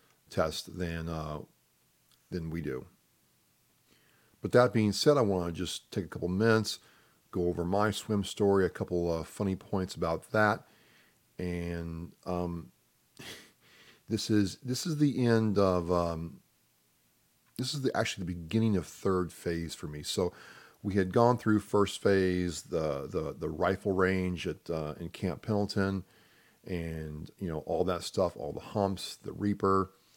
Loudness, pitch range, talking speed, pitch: -31 LUFS, 85-105 Hz, 155 wpm, 95 Hz